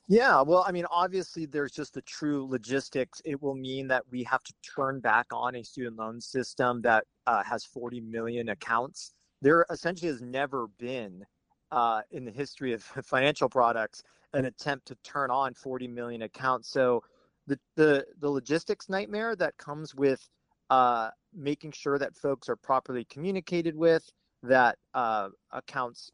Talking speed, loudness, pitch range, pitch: 165 wpm, -29 LUFS, 125-150 Hz, 135 Hz